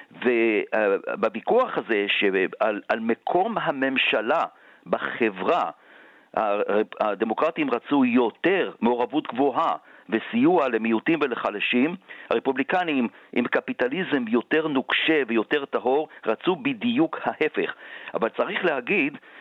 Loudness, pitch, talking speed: -24 LUFS, 150 Hz, 85 wpm